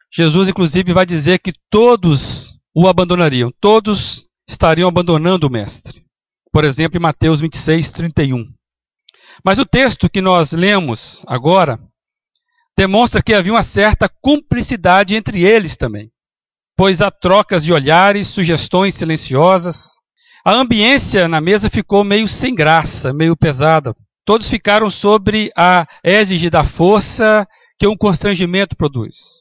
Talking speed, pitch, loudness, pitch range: 125 wpm, 180 Hz, -13 LUFS, 160-205 Hz